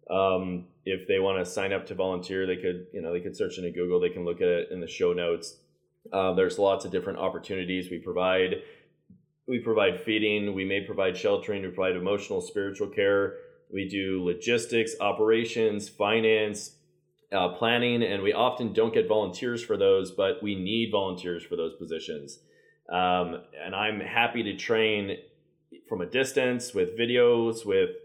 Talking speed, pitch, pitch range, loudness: 175 wpm, 110 Hz, 95-135 Hz, -27 LUFS